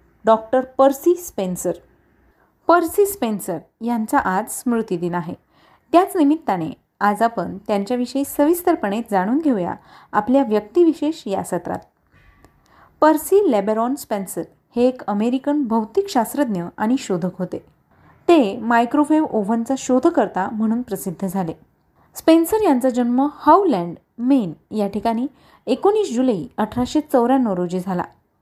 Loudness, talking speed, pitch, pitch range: -19 LUFS, 110 wpm, 245 Hz, 205-290 Hz